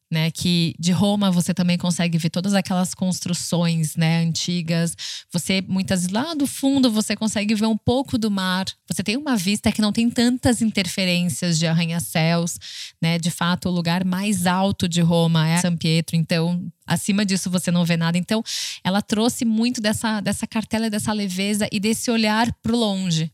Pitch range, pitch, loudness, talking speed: 170-215 Hz, 185 Hz, -21 LUFS, 180 wpm